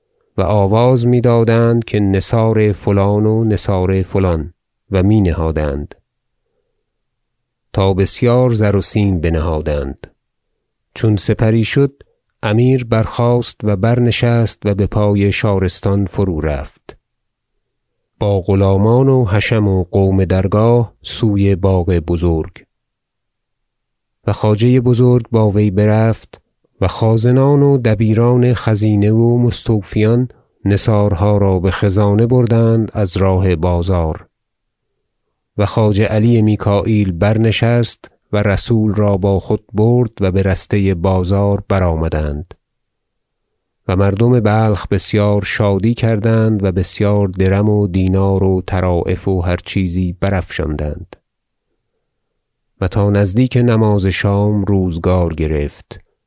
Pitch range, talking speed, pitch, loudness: 95-115 Hz, 110 wpm, 105 Hz, -14 LUFS